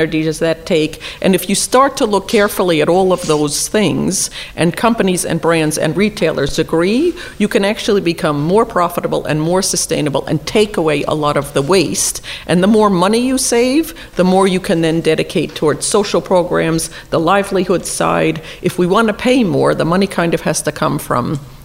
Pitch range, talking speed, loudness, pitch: 160-205 Hz, 195 wpm, -14 LUFS, 180 Hz